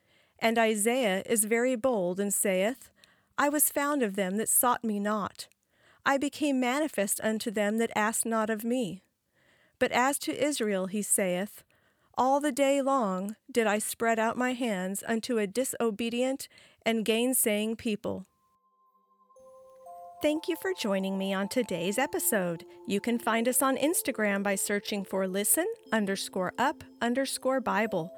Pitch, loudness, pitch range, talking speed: 230 Hz, -28 LUFS, 205-260 Hz, 150 wpm